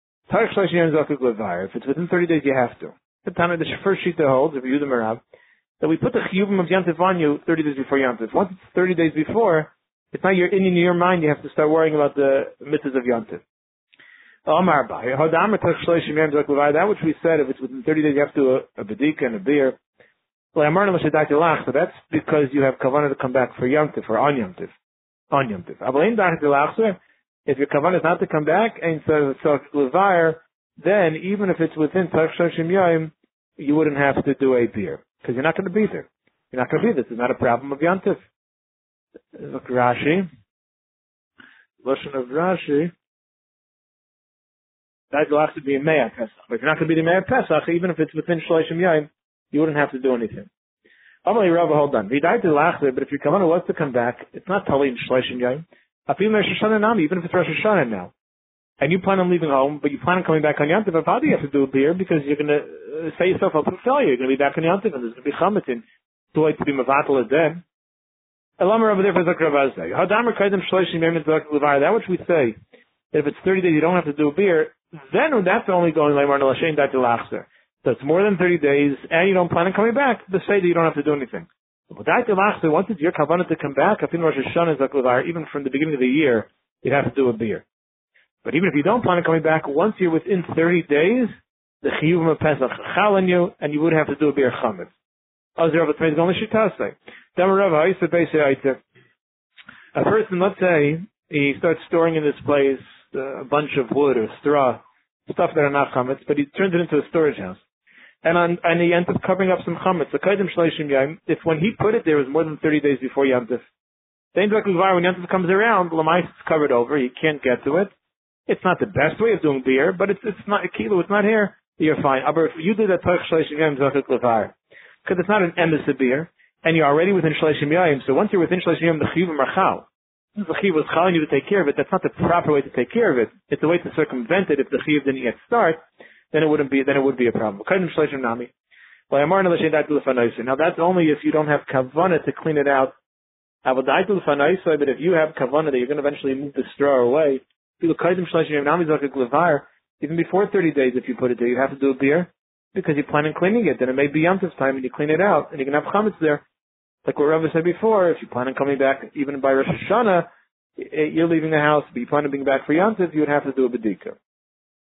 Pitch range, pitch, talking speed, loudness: 140-180 Hz, 155 Hz, 210 wpm, -20 LUFS